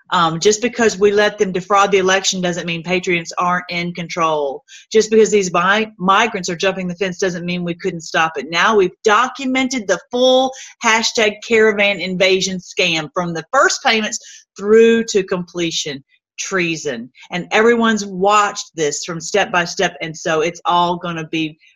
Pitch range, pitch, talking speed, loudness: 175-215 Hz, 190 Hz, 170 wpm, -16 LUFS